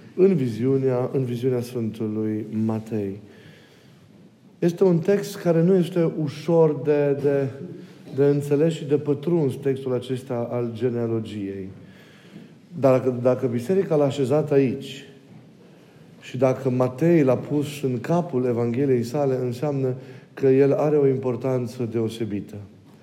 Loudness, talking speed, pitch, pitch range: -23 LUFS, 120 wpm, 130 Hz, 120-150 Hz